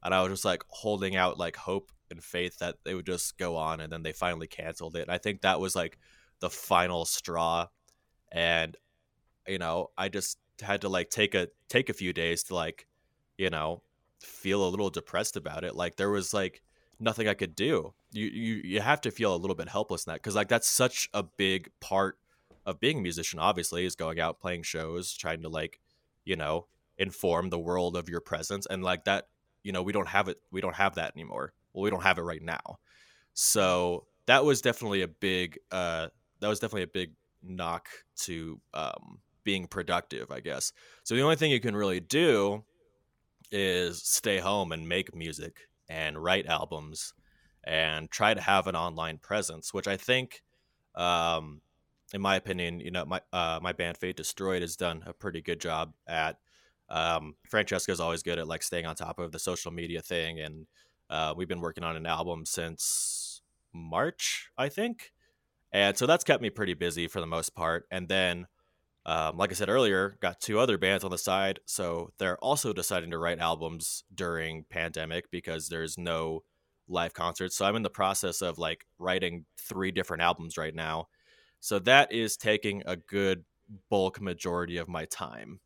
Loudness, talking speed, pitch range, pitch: -30 LUFS, 195 wpm, 85-95 Hz, 90 Hz